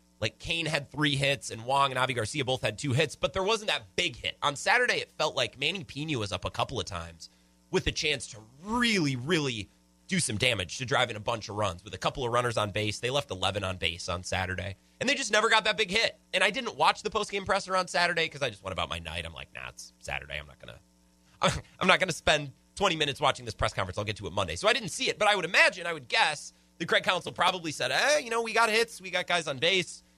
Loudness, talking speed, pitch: -28 LUFS, 275 wpm, 125 Hz